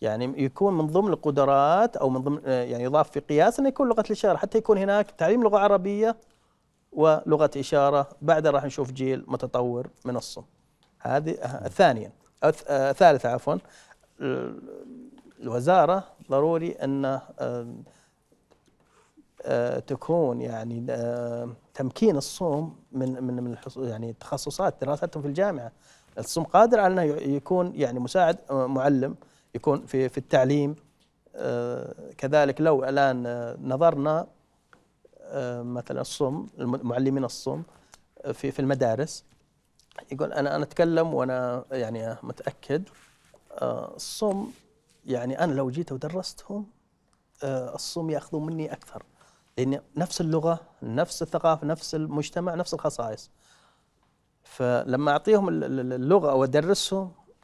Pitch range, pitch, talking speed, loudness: 130-175 Hz, 145 Hz, 115 wpm, -26 LUFS